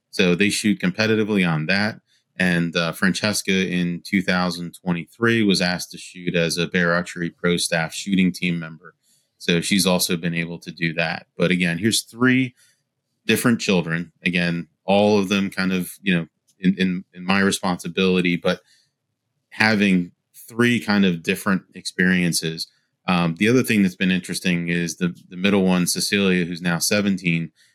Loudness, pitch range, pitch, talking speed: -21 LUFS, 85-100 Hz, 90 Hz, 160 wpm